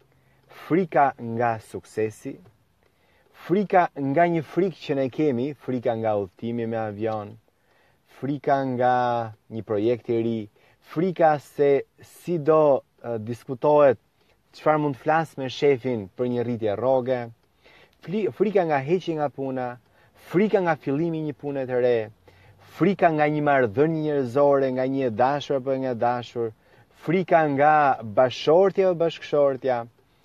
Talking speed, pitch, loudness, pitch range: 130 wpm, 135 Hz, -23 LUFS, 120-150 Hz